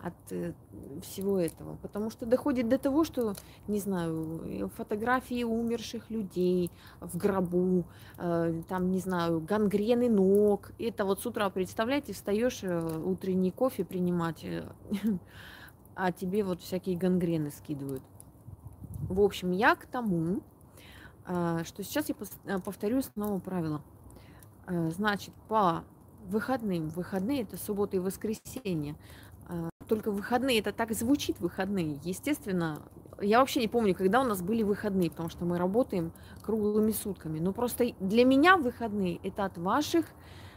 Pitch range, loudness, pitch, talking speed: 170-225 Hz, -31 LUFS, 195 Hz, 125 wpm